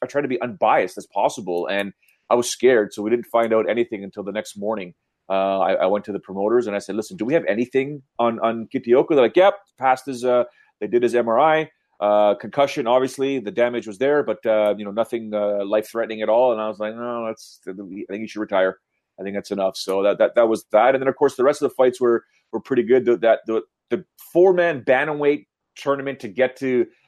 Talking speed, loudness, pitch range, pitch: 245 wpm, -21 LUFS, 105-135 Hz, 120 Hz